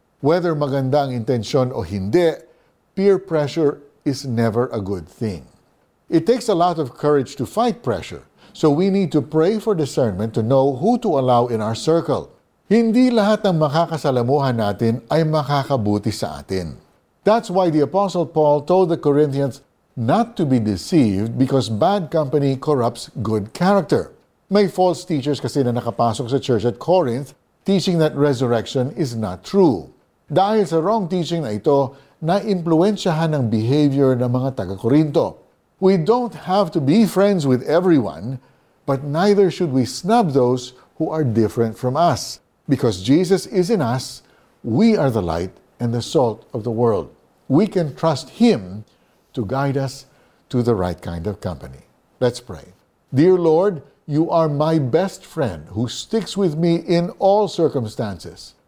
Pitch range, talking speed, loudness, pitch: 120-180 Hz, 155 wpm, -19 LUFS, 145 Hz